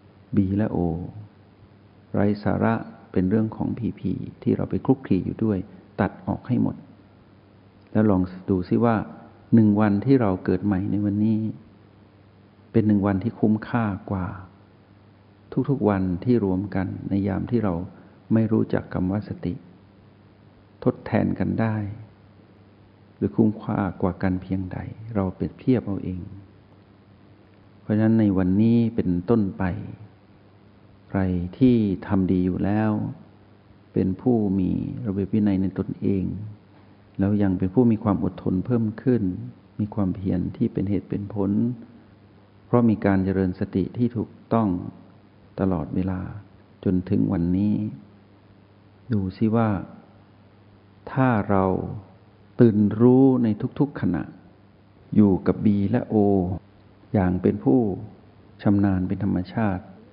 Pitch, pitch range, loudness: 100 Hz, 95-110 Hz, -23 LUFS